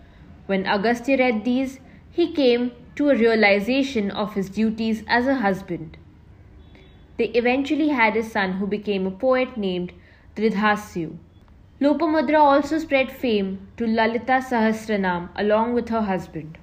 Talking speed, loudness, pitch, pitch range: 135 wpm, -21 LUFS, 220 Hz, 195-260 Hz